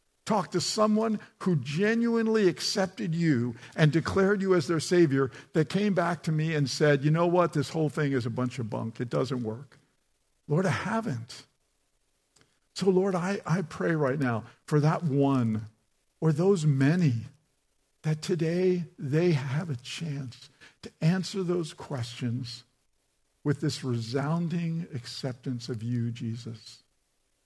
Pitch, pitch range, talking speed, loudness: 150 Hz, 130-175 Hz, 145 wpm, -28 LUFS